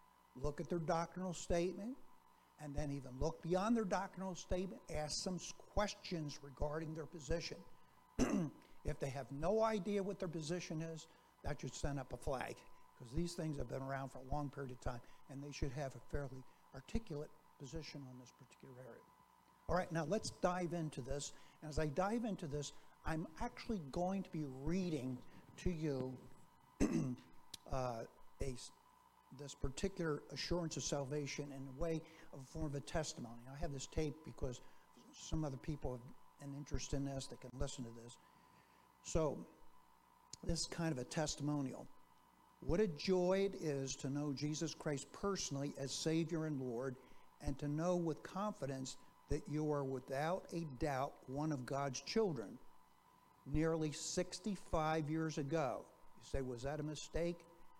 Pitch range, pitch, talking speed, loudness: 140-170 Hz, 150 Hz, 165 wpm, -43 LUFS